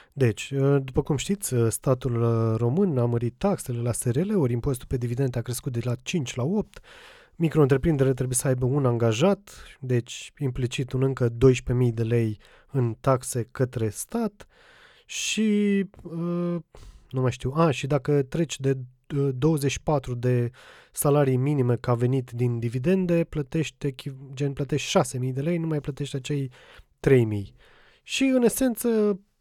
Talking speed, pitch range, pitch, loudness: 145 wpm, 125-160 Hz, 135 Hz, -25 LUFS